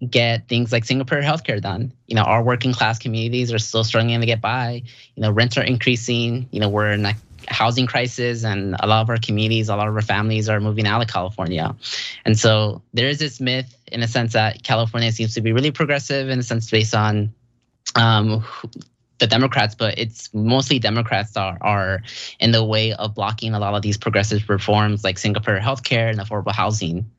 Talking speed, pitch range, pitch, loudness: 205 wpm, 105-120 Hz, 115 Hz, -20 LUFS